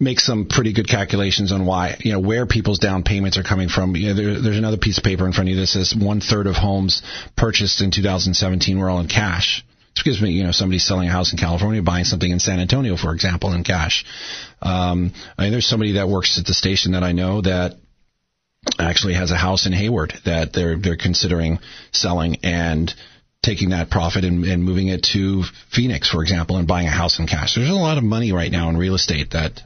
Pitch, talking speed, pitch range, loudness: 95 Hz, 235 wpm, 90-105 Hz, -19 LUFS